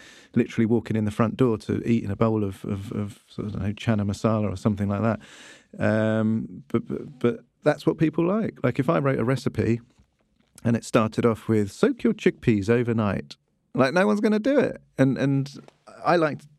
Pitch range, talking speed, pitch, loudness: 110-135 Hz, 210 wpm, 115 Hz, -24 LUFS